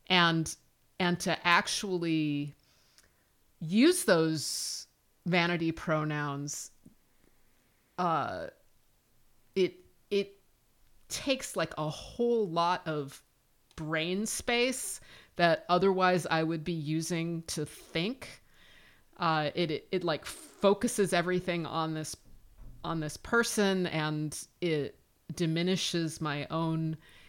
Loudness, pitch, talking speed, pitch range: -31 LUFS, 165 Hz, 95 wpm, 155-180 Hz